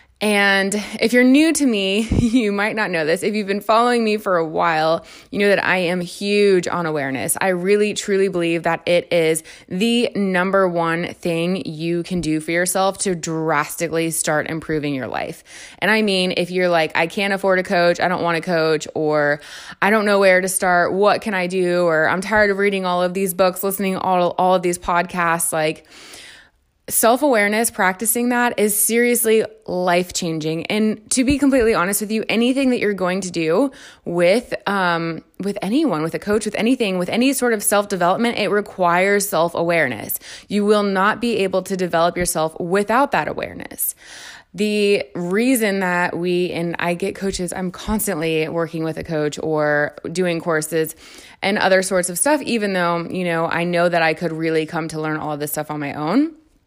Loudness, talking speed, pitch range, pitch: -18 LUFS, 195 wpm, 170-210 Hz, 185 Hz